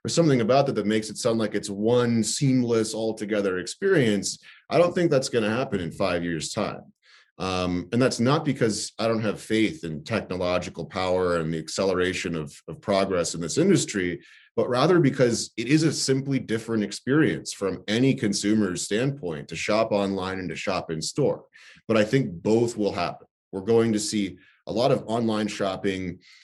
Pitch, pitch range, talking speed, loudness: 105 Hz, 90-115 Hz, 190 wpm, -25 LUFS